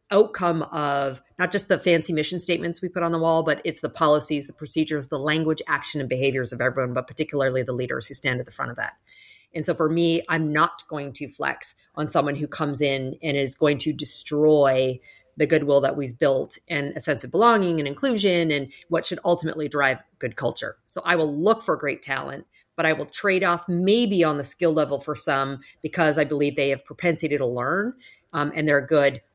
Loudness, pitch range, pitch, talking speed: -23 LUFS, 140-170 Hz, 150 Hz, 215 wpm